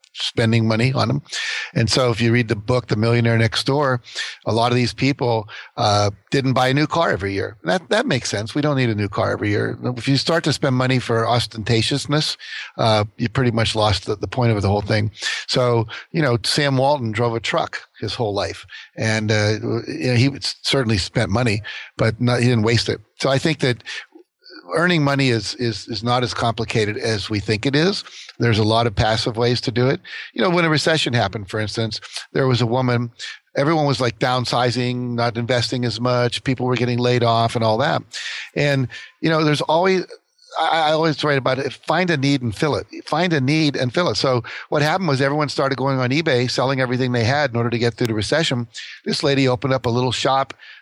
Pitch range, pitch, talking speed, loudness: 115-140 Hz, 125 Hz, 220 wpm, -19 LUFS